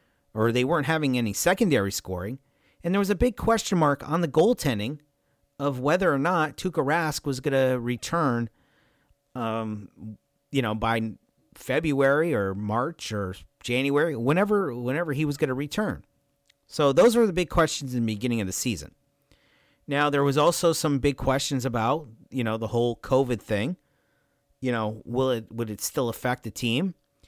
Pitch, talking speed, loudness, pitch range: 135 Hz, 170 wpm, -25 LUFS, 115-150 Hz